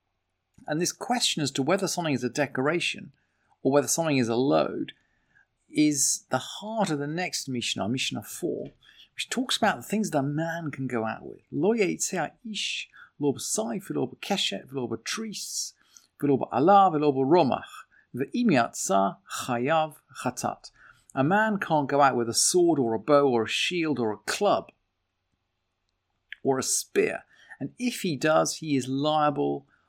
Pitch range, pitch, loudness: 120-170 Hz, 145 Hz, -26 LUFS